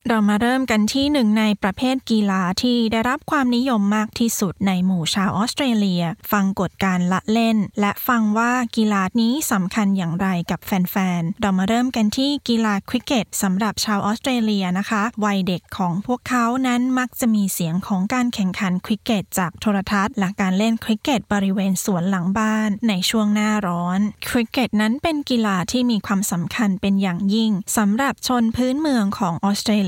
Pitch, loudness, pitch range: 210 Hz, -20 LUFS, 195-235 Hz